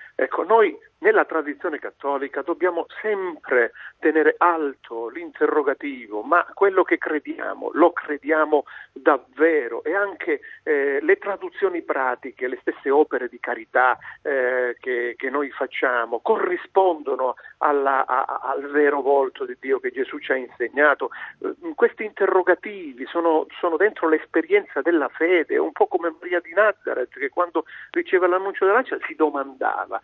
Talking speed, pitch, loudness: 140 wpm, 185 Hz, -22 LUFS